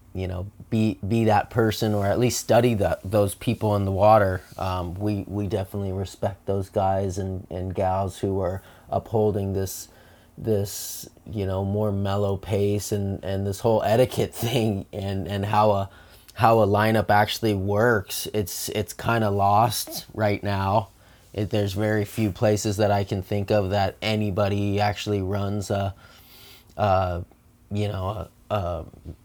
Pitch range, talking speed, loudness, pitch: 95-110 Hz, 160 wpm, -24 LUFS, 100 Hz